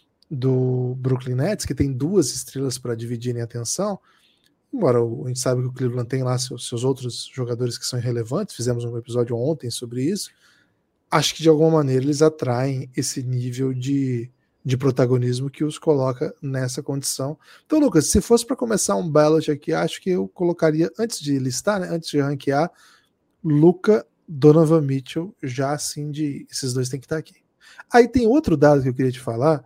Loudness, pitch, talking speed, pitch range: -21 LUFS, 140 Hz, 185 wpm, 125-160 Hz